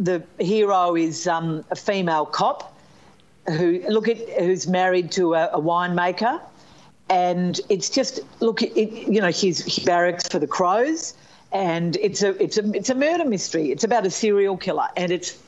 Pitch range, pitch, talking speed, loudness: 175-215 Hz, 185 Hz, 170 wpm, -22 LUFS